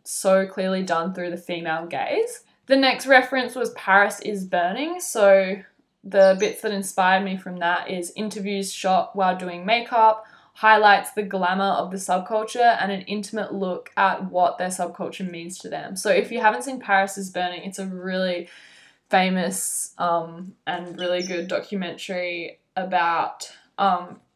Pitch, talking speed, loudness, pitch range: 190 Hz, 160 wpm, -22 LUFS, 180-210 Hz